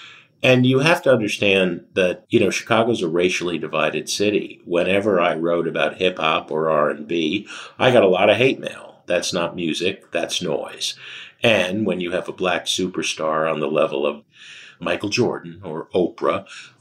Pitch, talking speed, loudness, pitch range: 90 Hz, 170 wpm, -20 LUFS, 80-105 Hz